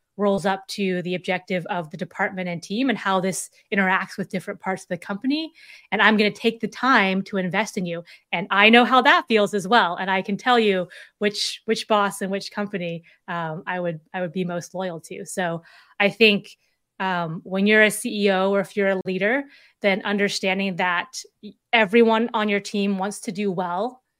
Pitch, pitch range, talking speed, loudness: 200 Hz, 185-215 Hz, 205 wpm, -22 LUFS